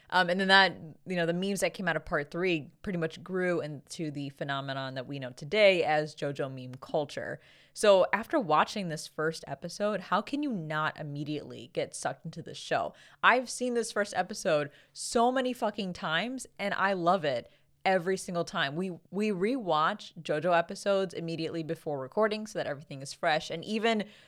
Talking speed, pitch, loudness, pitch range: 185 wpm, 170 Hz, -30 LUFS, 155-200 Hz